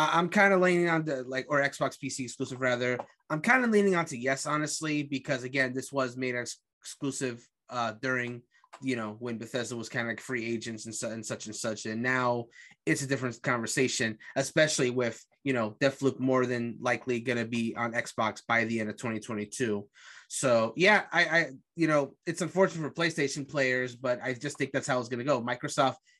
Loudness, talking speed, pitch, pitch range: -29 LUFS, 210 wpm, 130 Hz, 120-145 Hz